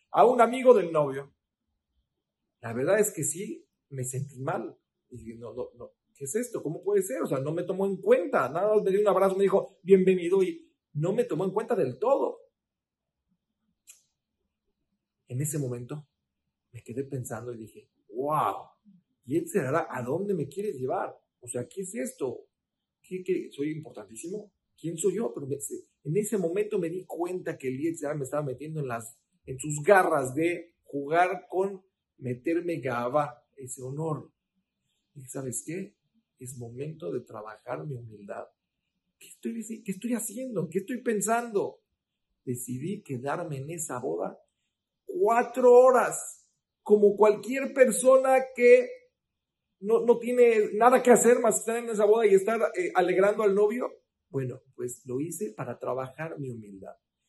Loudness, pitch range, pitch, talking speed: -27 LUFS, 135-230 Hz, 185 Hz, 165 wpm